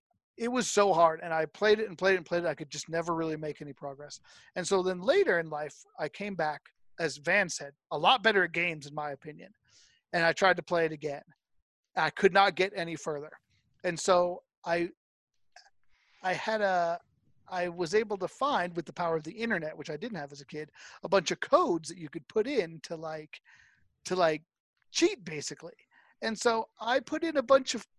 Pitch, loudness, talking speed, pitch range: 170 Hz, -30 LUFS, 220 wpm, 155-200 Hz